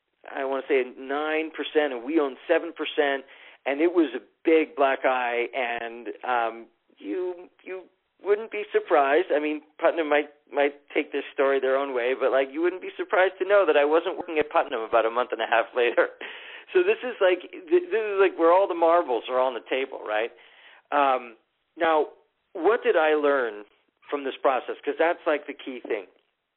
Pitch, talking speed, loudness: 155 Hz, 200 wpm, -25 LUFS